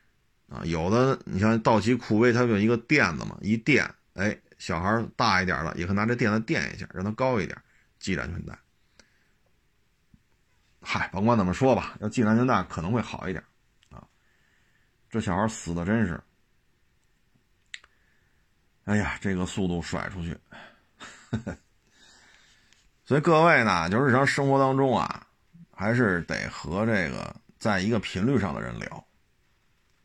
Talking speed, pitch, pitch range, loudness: 215 characters per minute, 110 Hz, 95-120 Hz, -26 LUFS